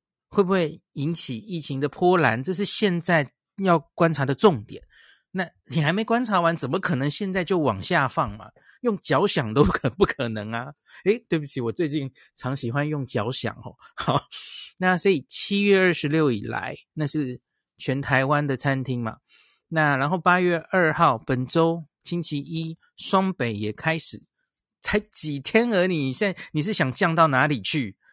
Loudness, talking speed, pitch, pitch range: -24 LUFS, 245 characters per minute, 155 Hz, 135-180 Hz